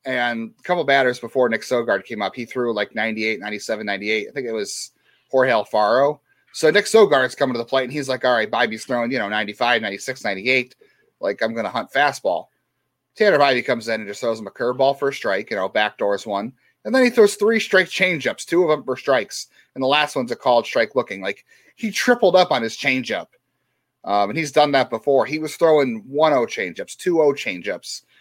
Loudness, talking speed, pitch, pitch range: -20 LUFS, 230 wpm, 130 Hz, 115-165 Hz